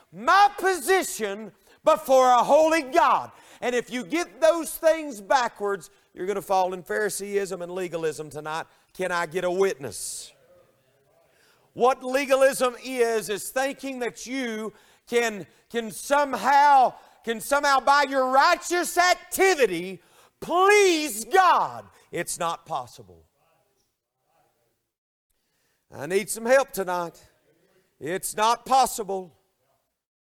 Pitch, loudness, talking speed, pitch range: 235 Hz, -23 LUFS, 110 wpm, 190-285 Hz